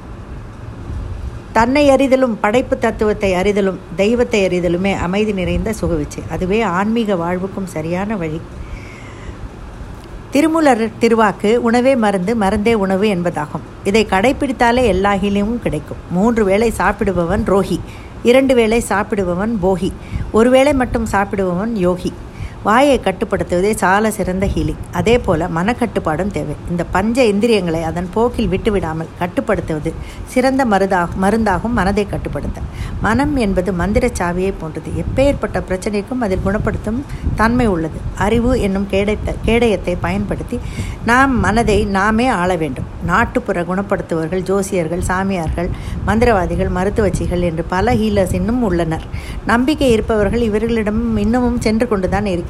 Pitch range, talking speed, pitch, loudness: 180-230 Hz, 115 wpm, 200 Hz, -16 LUFS